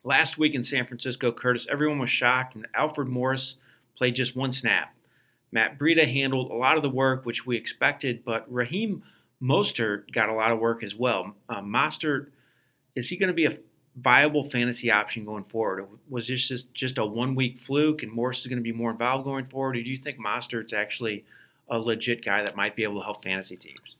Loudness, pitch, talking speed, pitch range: -26 LUFS, 125 Hz, 210 wpm, 115-135 Hz